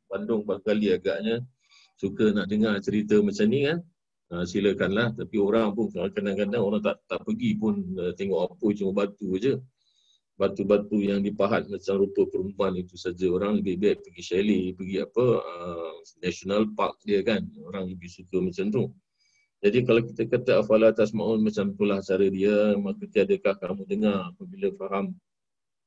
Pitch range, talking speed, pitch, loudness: 95-115 Hz, 160 wpm, 105 Hz, -26 LUFS